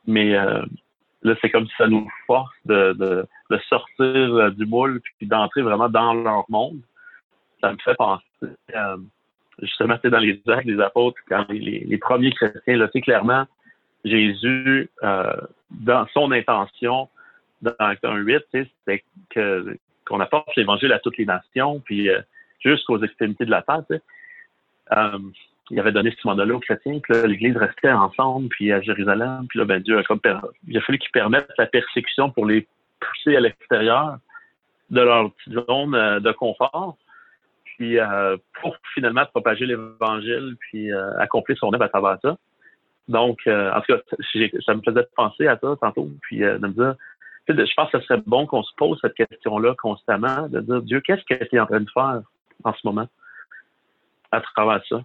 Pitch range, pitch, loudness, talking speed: 105-130 Hz, 115 Hz, -20 LUFS, 185 wpm